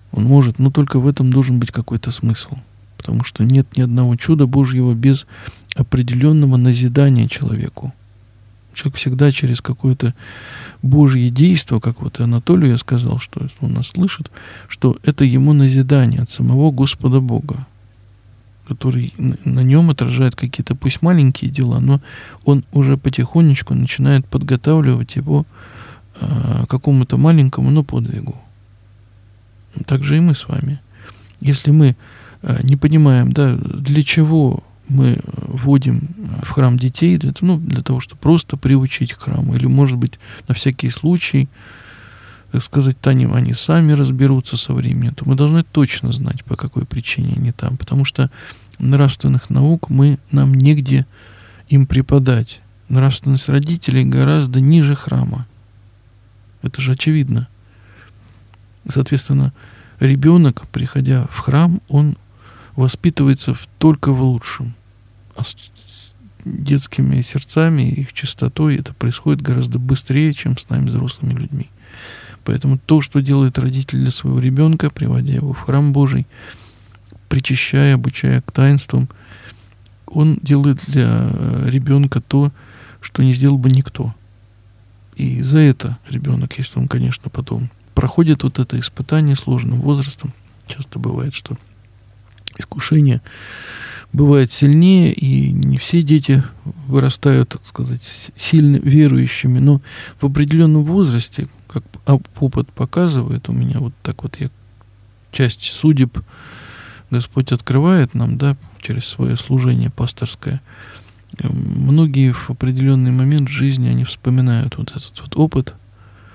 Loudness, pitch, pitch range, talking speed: -15 LUFS, 130 Hz, 115-140 Hz, 125 wpm